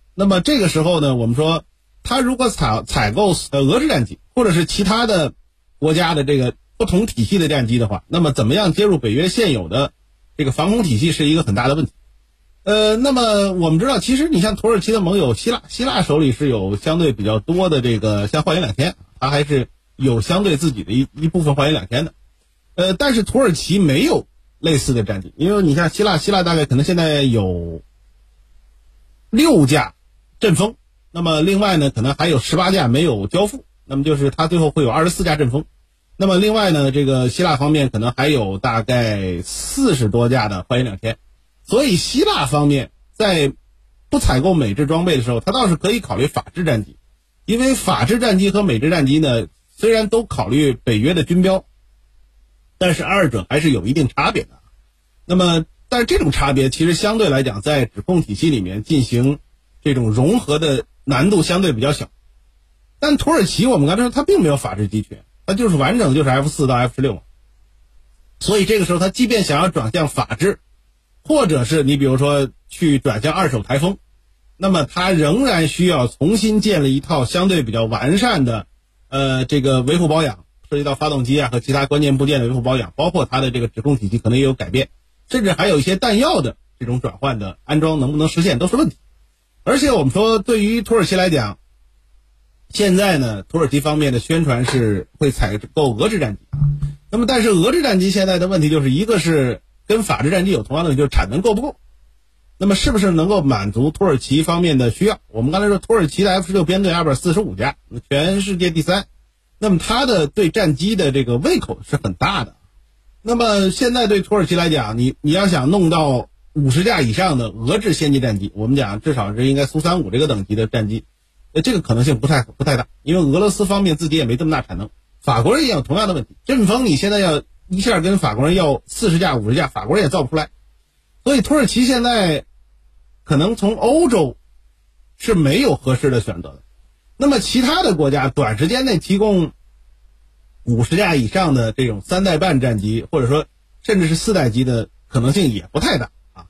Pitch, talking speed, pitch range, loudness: 150 Hz, 310 characters per minute, 125-185 Hz, -17 LUFS